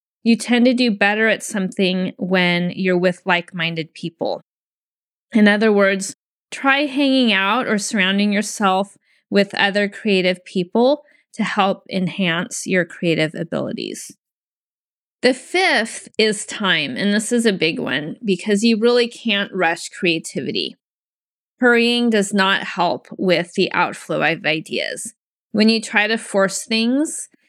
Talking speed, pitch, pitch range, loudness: 140 wpm, 205 Hz, 185-235 Hz, -18 LUFS